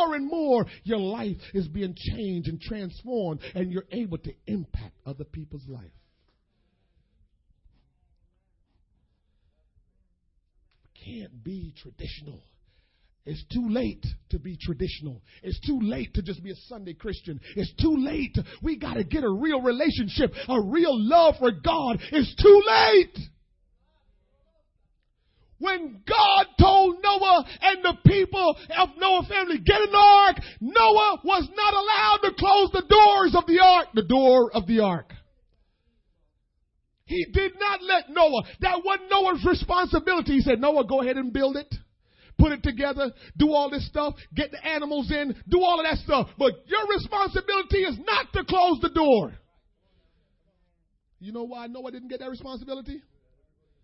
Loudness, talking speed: -22 LUFS, 145 wpm